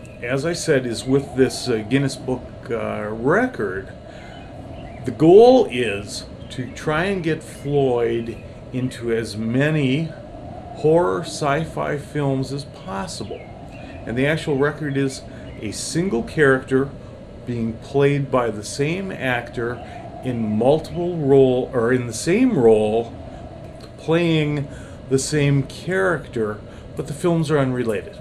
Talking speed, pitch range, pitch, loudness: 125 wpm, 115-145 Hz, 130 Hz, -20 LUFS